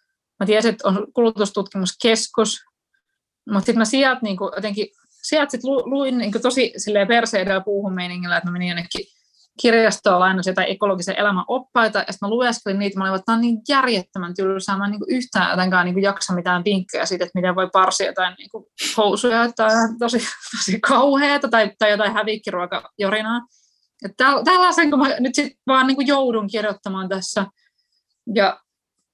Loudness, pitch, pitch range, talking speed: -19 LUFS, 215 Hz, 195-245 Hz, 150 wpm